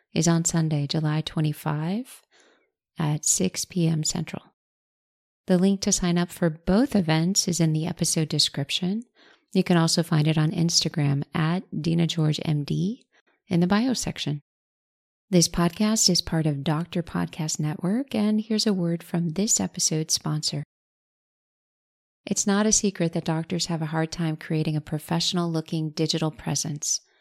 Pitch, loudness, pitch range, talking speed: 170 Hz, -24 LUFS, 155-185 Hz, 150 wpm